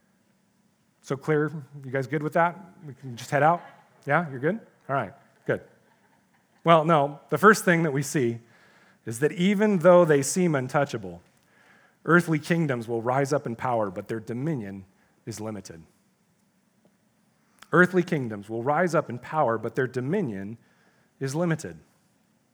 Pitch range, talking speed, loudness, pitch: 120-175 Hz, 150 wpm, -25 LUFS, 150 Hz